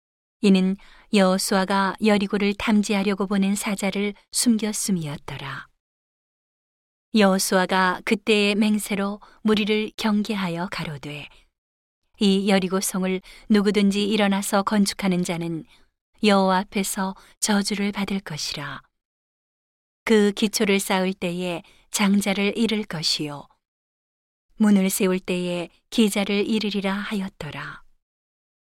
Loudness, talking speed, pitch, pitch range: -22 LUFS, 240 characters per minute, 200 Hz, 185-210 Hz